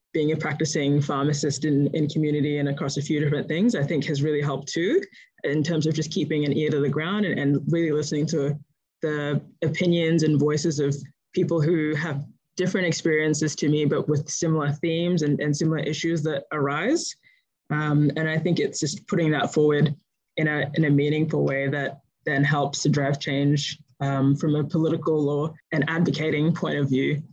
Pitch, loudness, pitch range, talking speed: 150 Hz, -24 LUFS, 145-160 Hz, 190 wpm